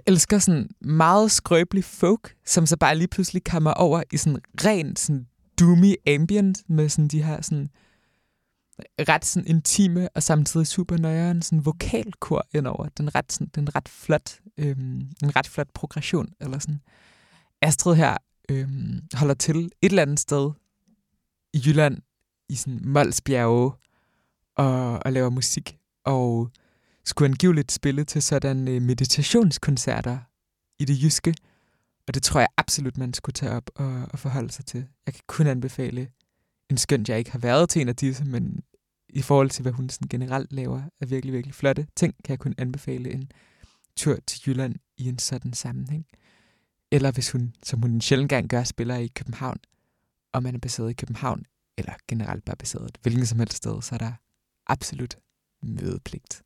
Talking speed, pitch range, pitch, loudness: 165 wpm, 125-155 Hz, 140 Hz, -24 LUFS